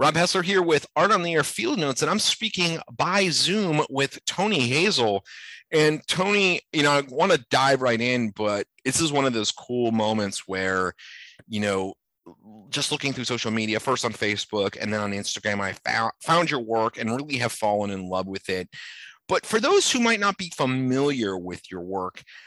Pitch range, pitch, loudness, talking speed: 105-155 Hz, 120 Hz, -23 LUFS, 200 wpm